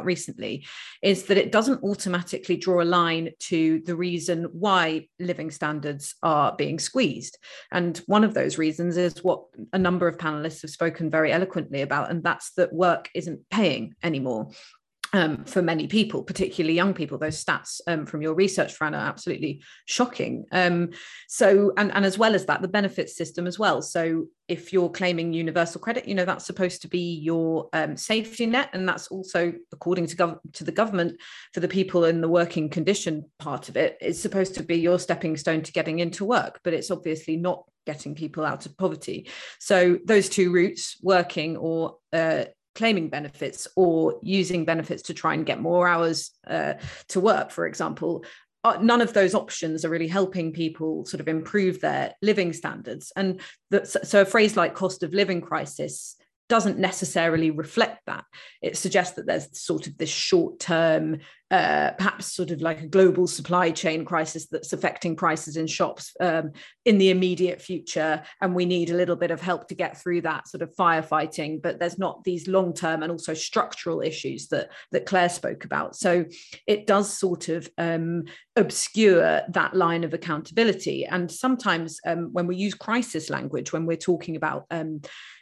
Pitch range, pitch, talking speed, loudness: 165-190 Hz, 175 Hz, 185 wpm, -25 LUFS